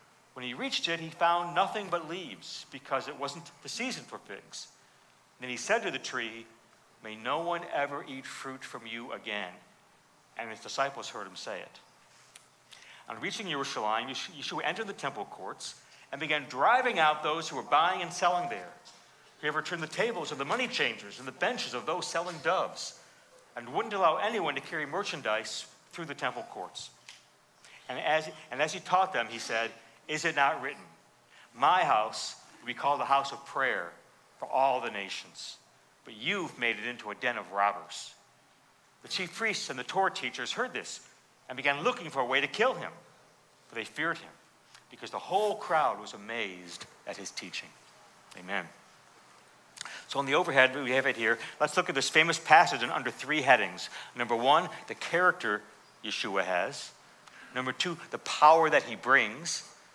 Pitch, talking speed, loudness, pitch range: 135 Hz, 180 wpm, -30 LUFS, 115-165 Hz